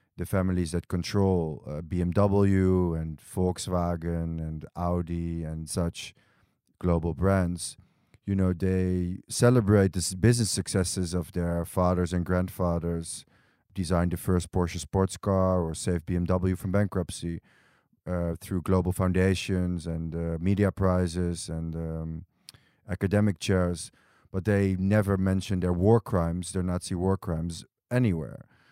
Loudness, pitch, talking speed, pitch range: -28 LUFS, 90 Hz, 130 wpm, 85-95 Hz